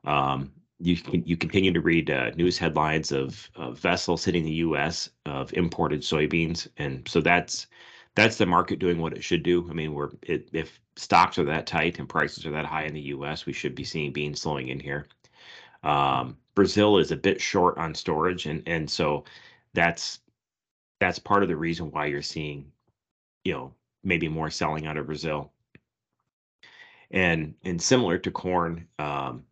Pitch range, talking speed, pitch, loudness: 75-85 Hz, 180 wpm, 80 Hz, -26 LUFS